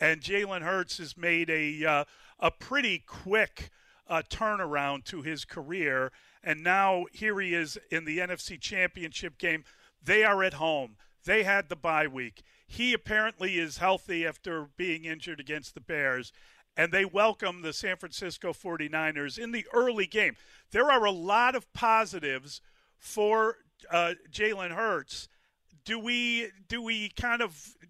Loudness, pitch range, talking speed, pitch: -29 LUFS, 160-215 Hz, 155 wpm, 180 Hz